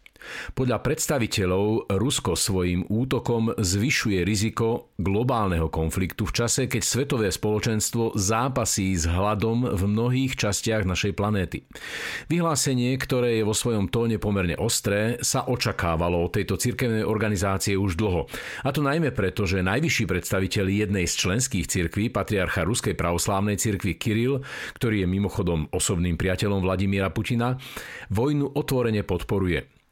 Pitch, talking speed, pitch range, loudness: 105 Hz, 130 wpm, 95-120 Hz, -24 LUFS